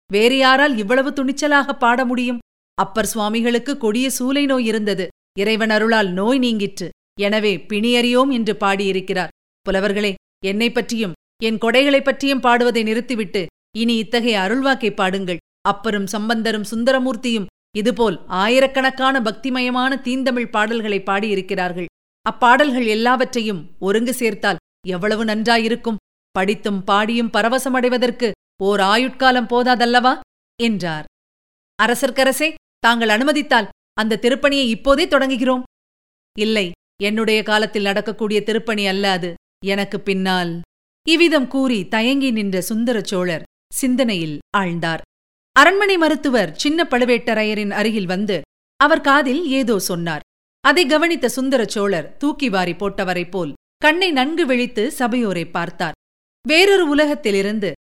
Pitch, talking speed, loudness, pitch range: 225 Hz, 105 wpm, -18 LUFS, 200-260 Hz